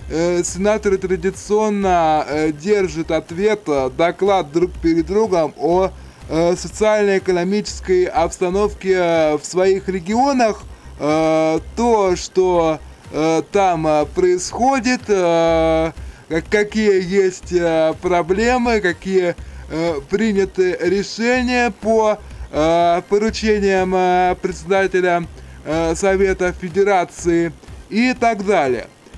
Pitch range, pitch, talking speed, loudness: 165-205 Hz, 185 Hz, 65 wpm, -17 LUFS